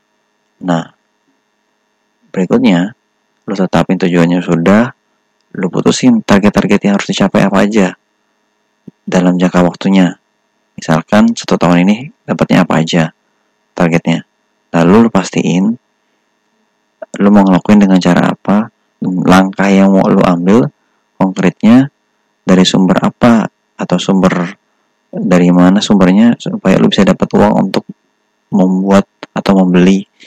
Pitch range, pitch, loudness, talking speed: 90-105 Hz, 100 Hz, -10 LUFS, 115 wpm